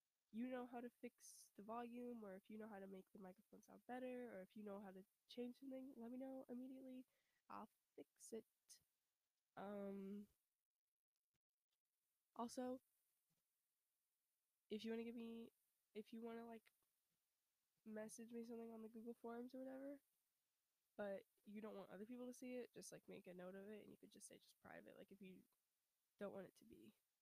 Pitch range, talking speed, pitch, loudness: 205-245 Hz, 190 wpm, 230 Hz, -57 LUFS